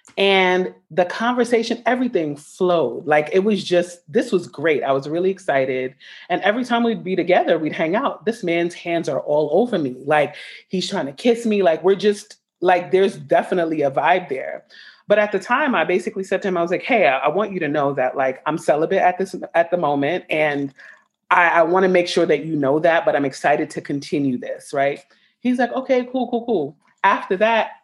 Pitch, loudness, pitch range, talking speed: 180 Hz, -19 LUFS, 150-205 Hz, 220 wpm